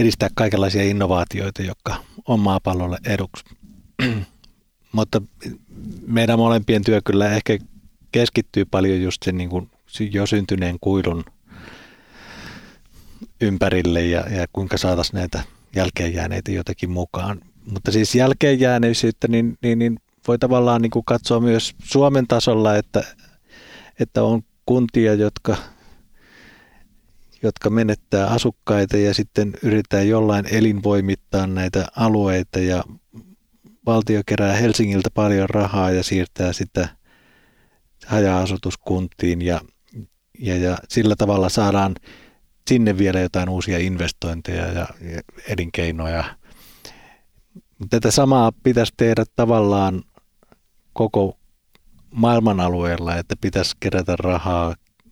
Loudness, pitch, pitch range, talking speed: -20 LUFS, 100 Hz, 90-115 Hz, 105 wpm